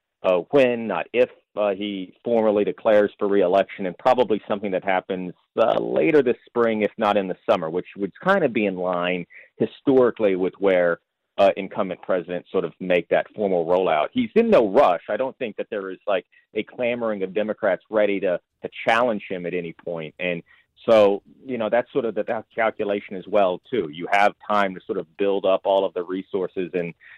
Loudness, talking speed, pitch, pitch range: -22 LUFS, 205 wpm, 100 Hz, 90-110 Hz